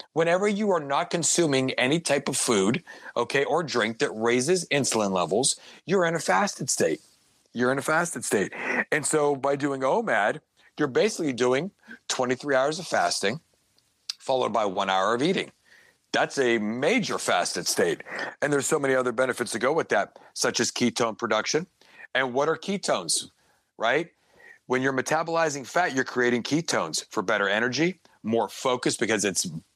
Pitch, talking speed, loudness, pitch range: 140 Hz, 165 wpm, -25 LUFS, 125-165 Hz